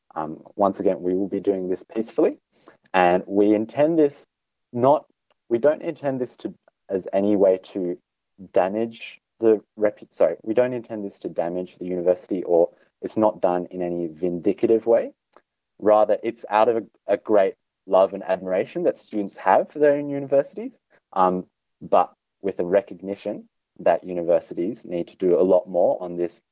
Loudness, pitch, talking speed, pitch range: -23 LUFS, 100 Hz, 170 wpm, 90-115 Hz